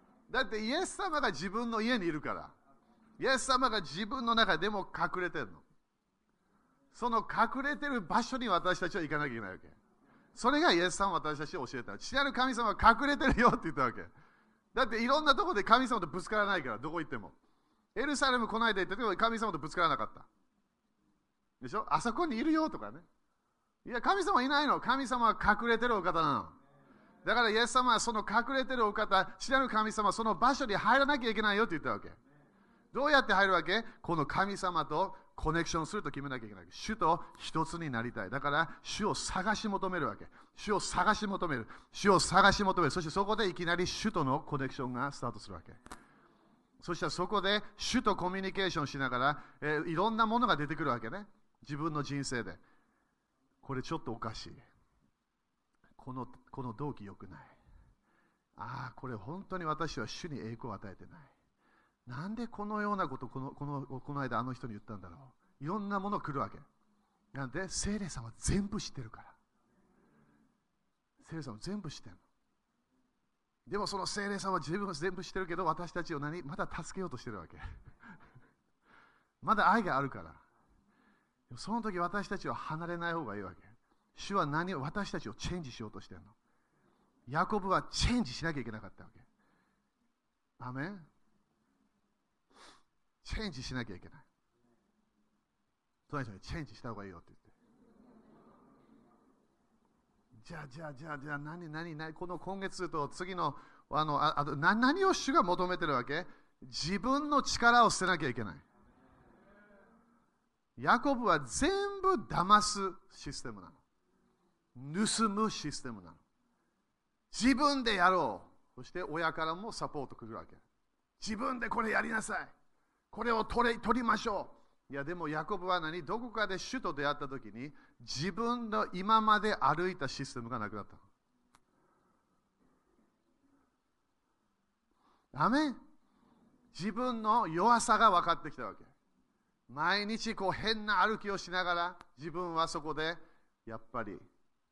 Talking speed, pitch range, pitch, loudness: 325 characters per minute, 140-220 Hz, 180 Hz, -33 LUFS